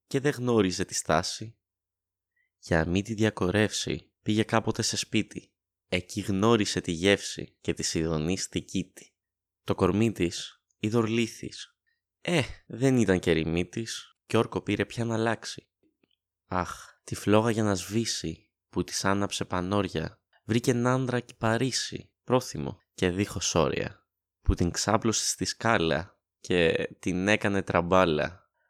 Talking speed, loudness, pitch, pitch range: 130 wpm, -28 LUFS, 100 Hz, 90-115 Hz